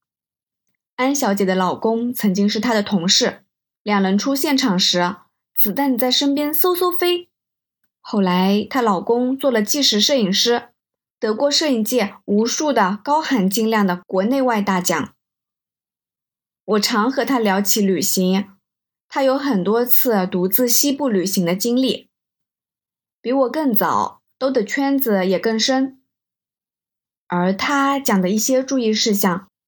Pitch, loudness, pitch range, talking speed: 230 Hz, -18 LUFS, 200-265 Hz, 200 characters per minute